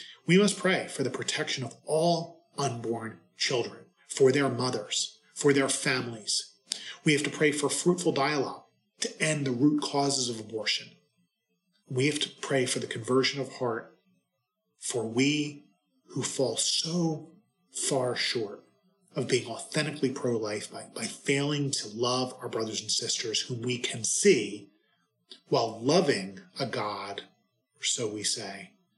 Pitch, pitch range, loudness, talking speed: 140 Hz, 125-160 Hz, -29 LUFS, 150 wpm